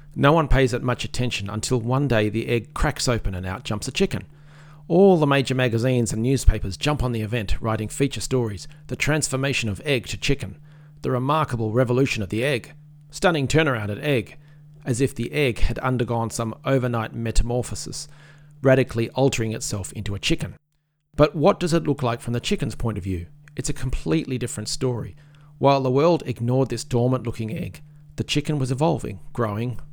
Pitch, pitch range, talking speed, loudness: 130 Hz, 115-150 Hz, 185 wpm, -23 LUFS